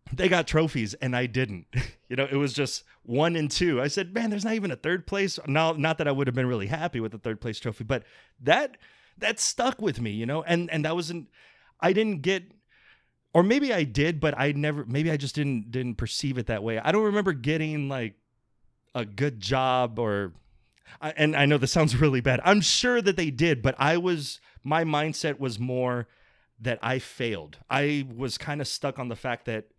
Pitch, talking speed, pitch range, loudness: 145 Hz, 220 wpm, 125-165 Hz, -26 LUFS